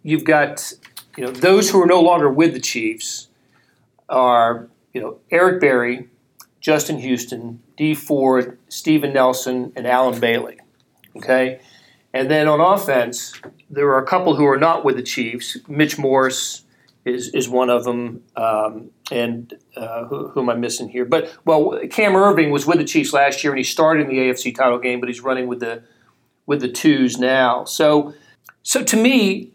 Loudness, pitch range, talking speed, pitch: -17 LUFS, 125-155 Hz, 175 wpm, 130 Hz